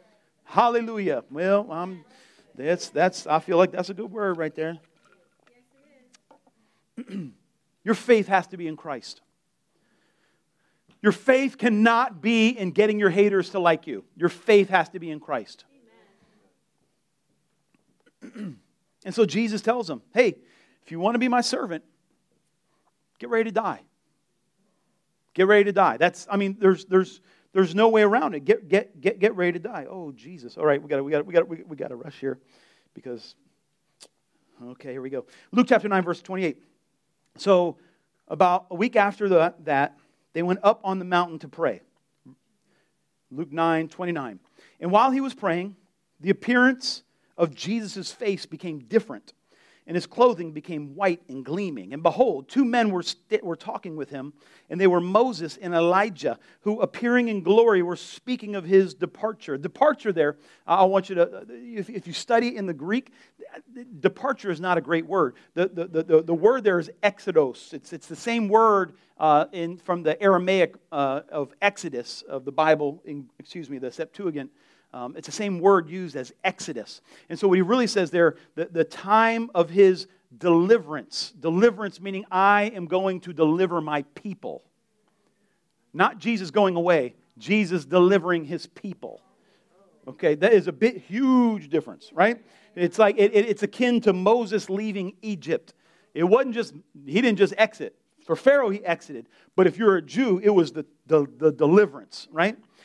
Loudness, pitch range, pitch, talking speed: -23 LUFS, 165-215 Hz, 185 Hz, 165 wpm